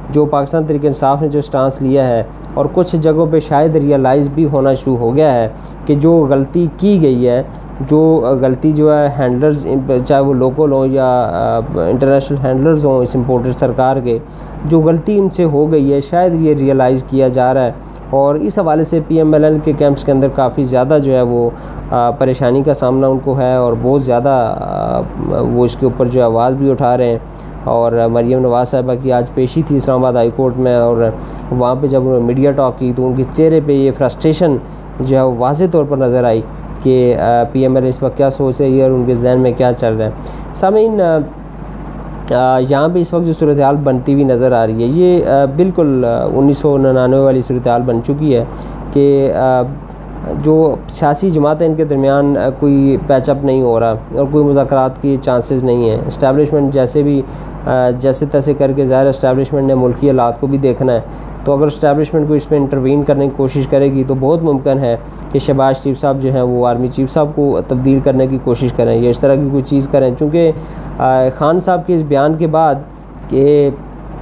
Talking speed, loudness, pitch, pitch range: 210 wpm, -12 LUFS, 135 Hz, 130-150 Hz